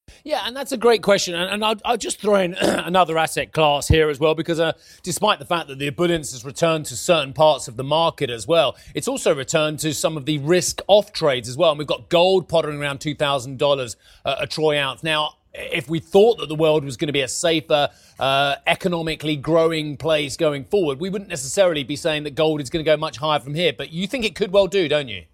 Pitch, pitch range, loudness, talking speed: 155 Hz, 145-175 Hz, -20 LUFS, 235 wpm